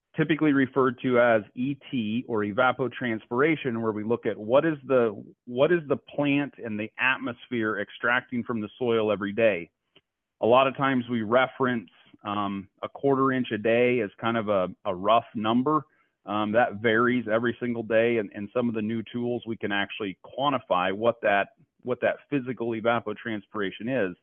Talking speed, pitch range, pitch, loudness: 175 wpm, 110-130 Hz, 120 Hz, -26 LUFS